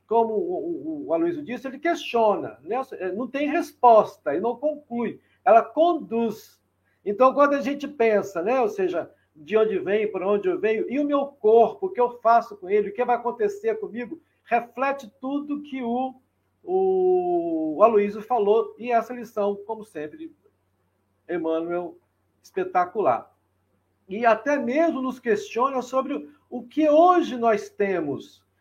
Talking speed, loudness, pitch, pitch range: 145 wpm, -23 LUFS, 235 Hz, 205-290 Hz